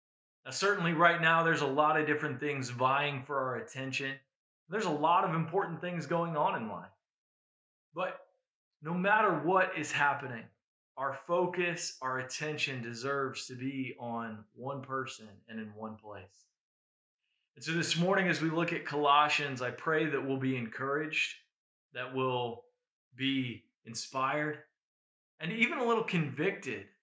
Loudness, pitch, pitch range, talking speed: -32 LUFS, 145 Hz, 130-170 Hz, 150 wpm